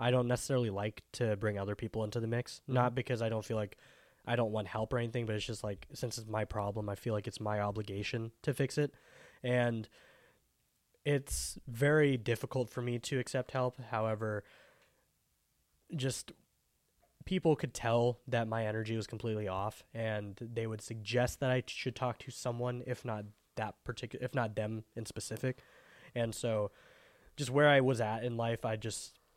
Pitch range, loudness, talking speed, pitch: 110-125 Hz, -36 LUFS, 185 wpm, 115 Hz